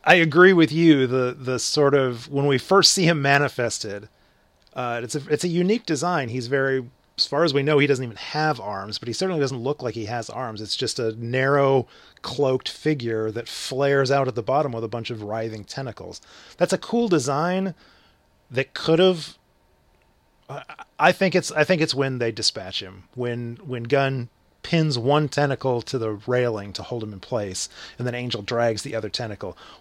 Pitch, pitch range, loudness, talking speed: 130 Hz, 115-150 Hz, -22 LUFS, 200 wpm